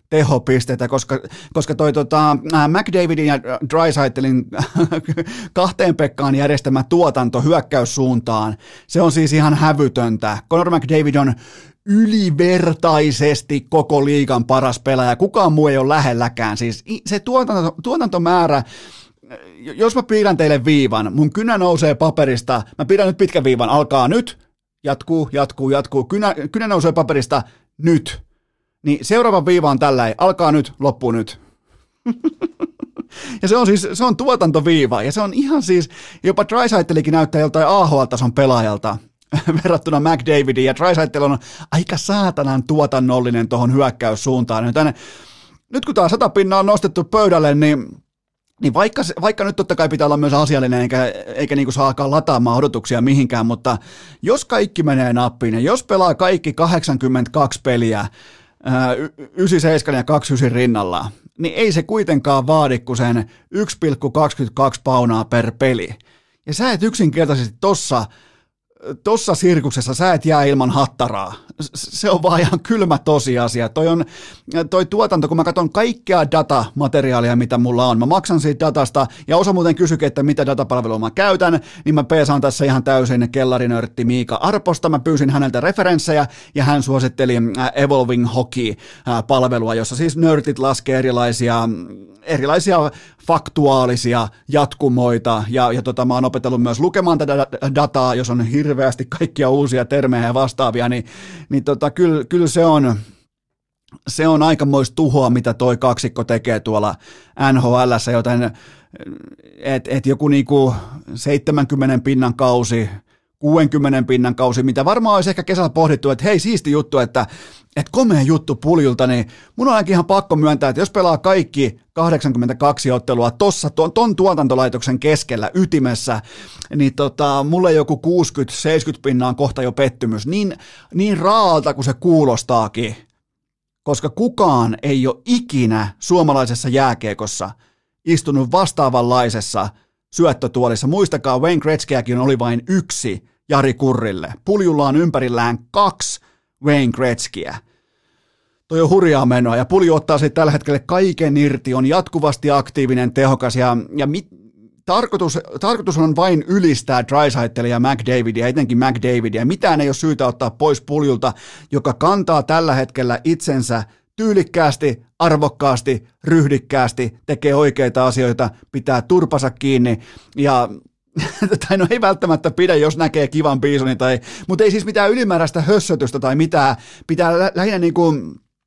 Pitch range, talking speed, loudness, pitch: 125-165 Hz, 140 wpm, -16 LUFS, 145 Hz